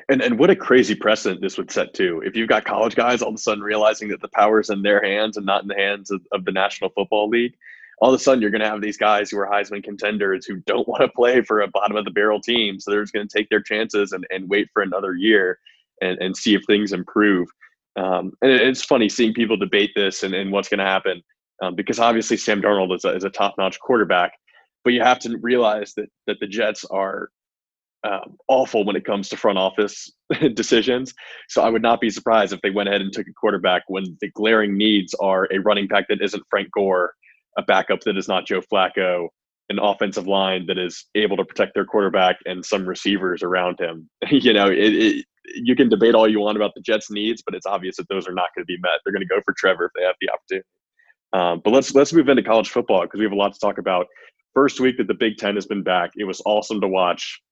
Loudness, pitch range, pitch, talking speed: -20 LUFS, 95-110 Hz, 105 Hz, 255 wpm